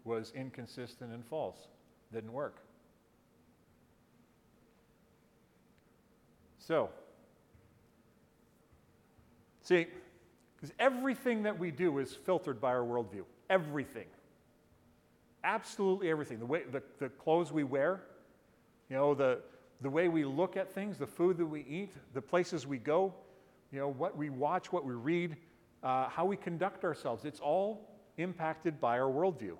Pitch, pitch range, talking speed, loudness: 155 Hz, 135-185 Hz, 130 wpm, -36 LUFS